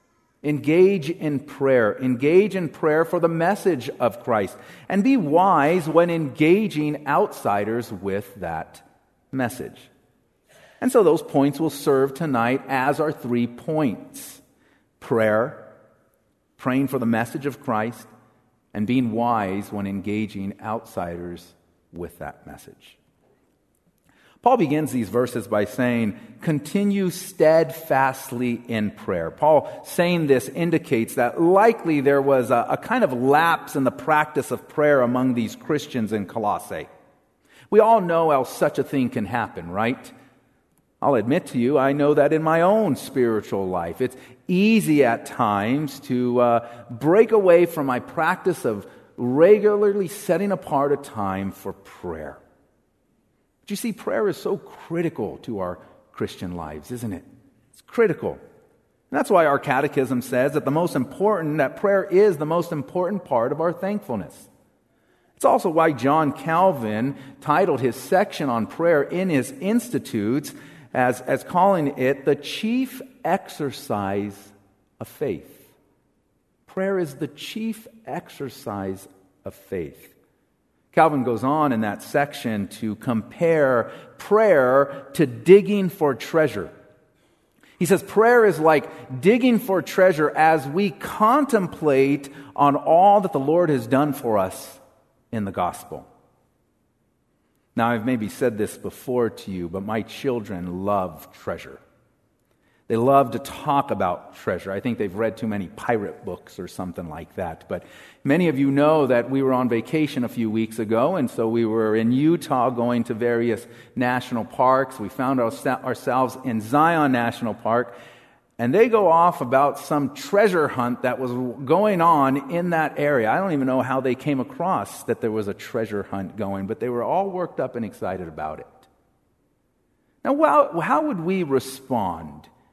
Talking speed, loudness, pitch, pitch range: 150 wpm, -21 LUFS, 140 Hz, 115-165 Hz